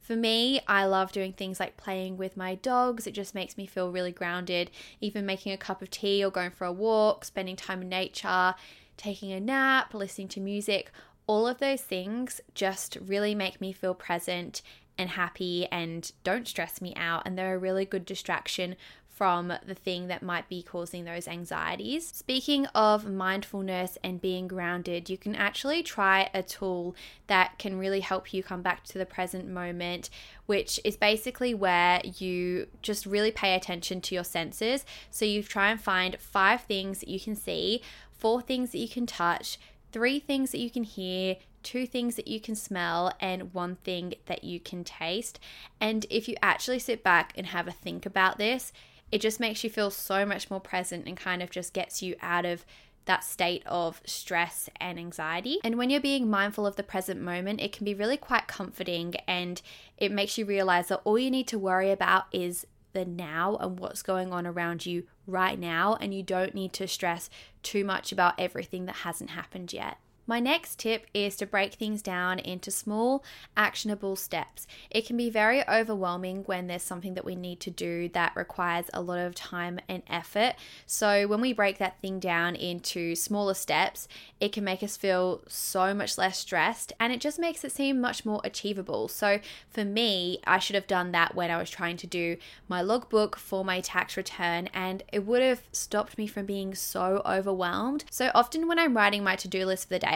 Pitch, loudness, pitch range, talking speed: 190 Hz, -30 LUFS, 180-215 Hz, 200 wpm